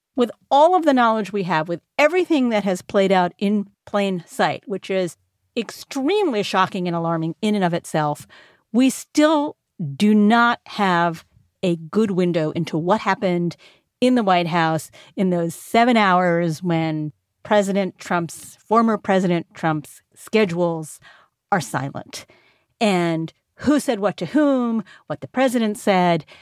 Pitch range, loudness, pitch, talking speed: 170-220 Hz, -20 LUFS, 190 Hz, 145 wpm